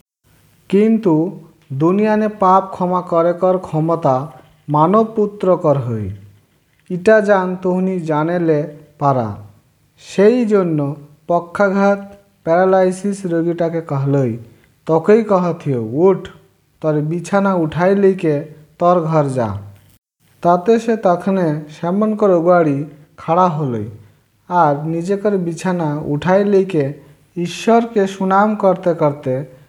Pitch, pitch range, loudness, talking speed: 170 Hz, 145-190 Hz, -16 LUFS, 95 wpm